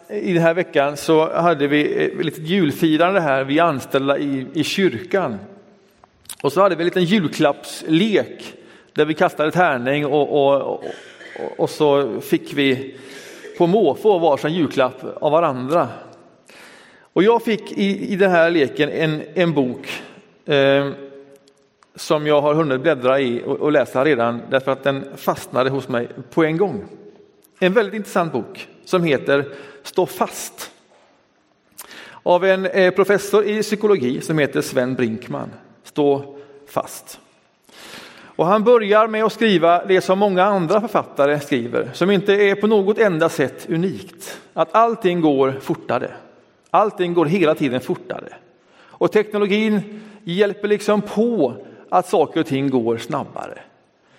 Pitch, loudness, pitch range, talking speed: 165 Hz, -18 LUFS, 140-200 Hz, 145 wpm